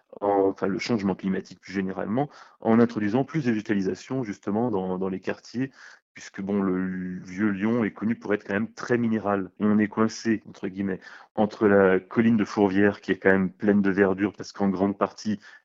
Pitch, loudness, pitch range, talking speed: 100 Hz, -25 LUFS, 95-110 Hz, 195 wpm